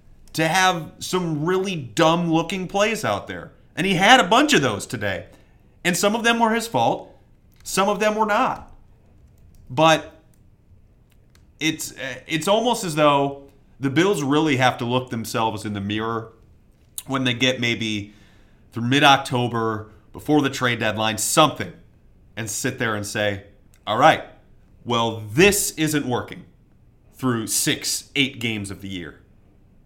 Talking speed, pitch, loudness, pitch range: 150 wpm, 125 Hz, -20 LUFS, 110-160 Hz